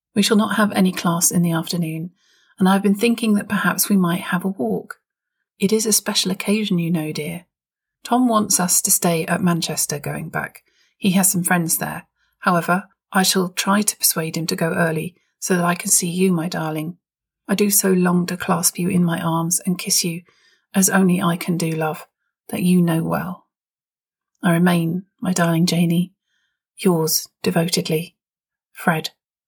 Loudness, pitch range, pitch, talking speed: -19 LUFS, 170-195 Hz, 180 Hz, 185 wpm